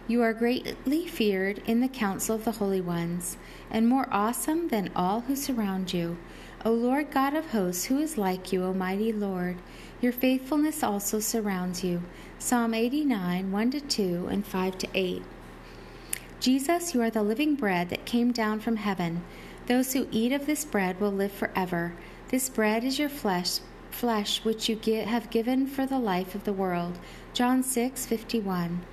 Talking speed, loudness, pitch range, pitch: 165 wpm, -28 LUFS, 190-250 Hz, 220 Hz